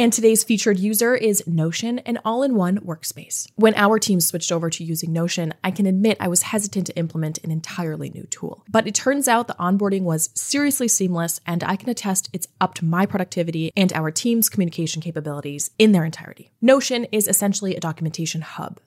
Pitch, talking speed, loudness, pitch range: 185 Hz, 195 wpm, -21 LUFS, 165-215 Hz